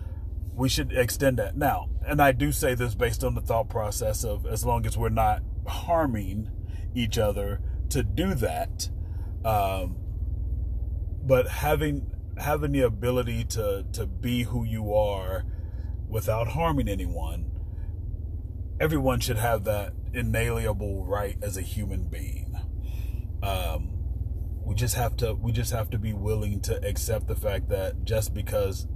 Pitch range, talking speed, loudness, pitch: 90-115 Hz, 145 wpm, -28 LUFS, 100 Hz